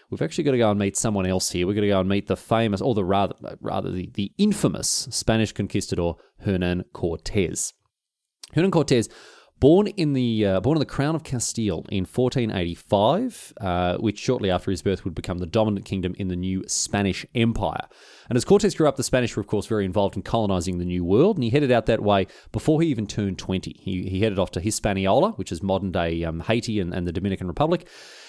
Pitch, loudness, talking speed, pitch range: 100 Hz, -23 LUFS, 220 wpm, 95-125 Hz